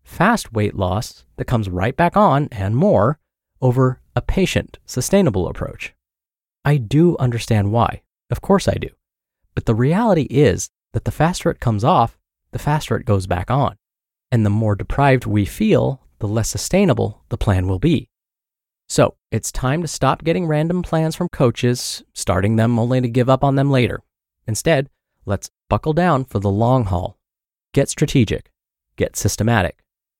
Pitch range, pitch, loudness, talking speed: 100-140 Hz, 120 Hz, -19 LUFS, 165 wpm